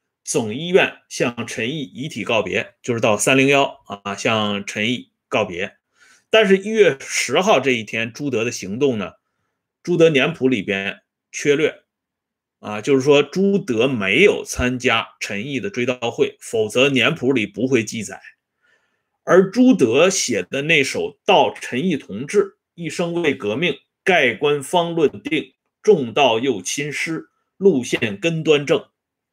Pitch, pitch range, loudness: 145 Hz, 120-195 Hz, -19 LUFS